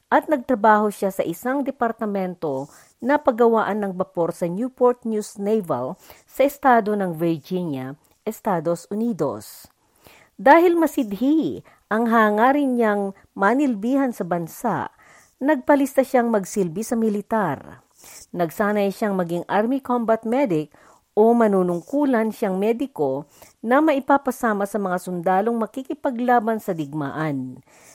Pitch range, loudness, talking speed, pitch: 190-255 Hz, -21 LUFS, 110 wpm, 220 Hz